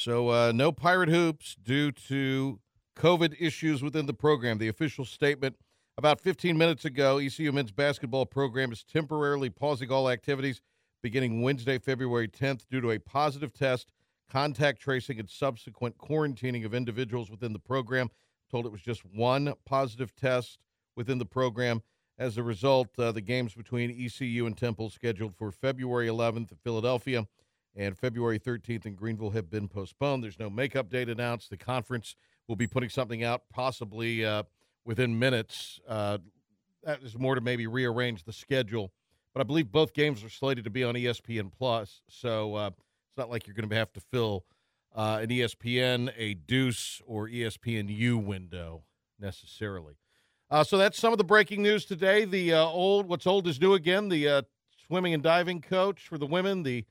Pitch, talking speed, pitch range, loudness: 125 Hz, 175 wpm, 115-140 Hz, -30 LUFS